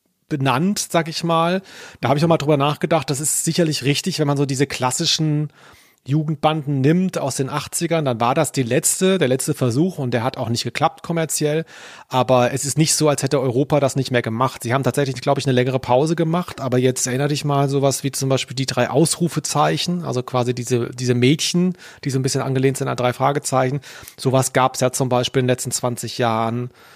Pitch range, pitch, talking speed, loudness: 130-155 Hz, 140 Hz, 220 wpm, -19 LUFS